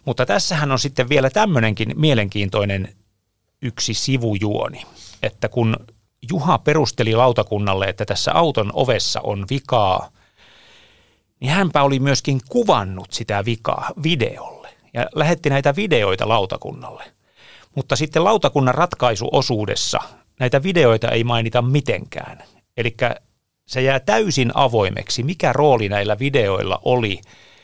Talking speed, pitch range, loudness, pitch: 115 wpm, 110-145 Hz, -19 LUFS, 125 Hz